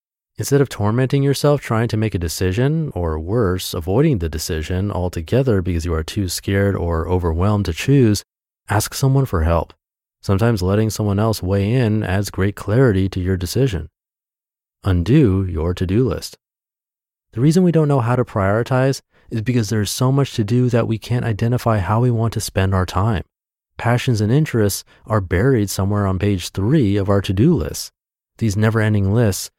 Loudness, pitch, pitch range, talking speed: -18 LUFS, 105 Hz, 95-125 Hz, 180 wpm